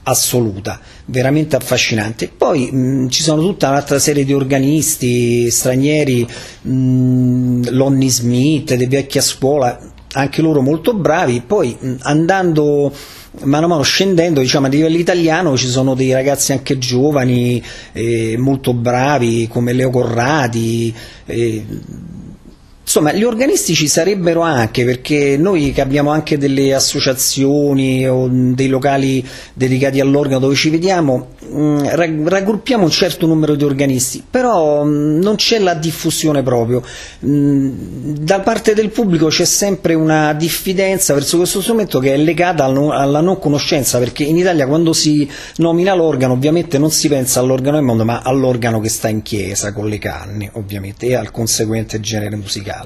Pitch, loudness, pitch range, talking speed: 140 Hz, -14 LUFS, 125-155 Hz, 145 wpm